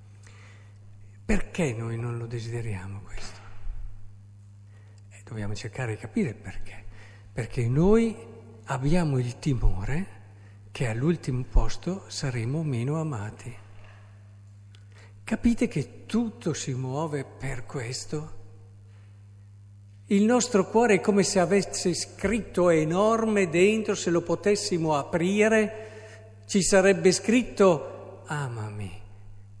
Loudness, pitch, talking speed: -26 LUFS, 120 Hz, 95 wpm